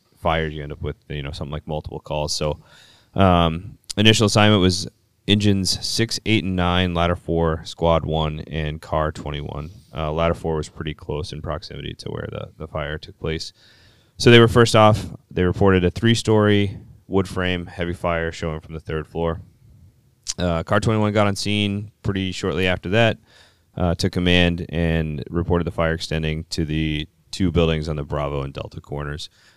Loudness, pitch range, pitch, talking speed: -21 LUFS, 80-100 Hz, 85 Hz, 180 wpm